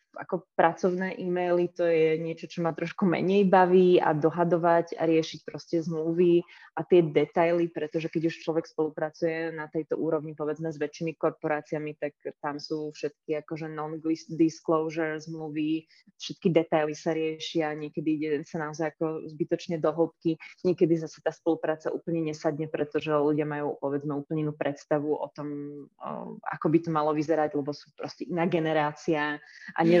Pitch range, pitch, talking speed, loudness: 155-170 Hz, 160 Hz, 155 wpm, -28 LUFS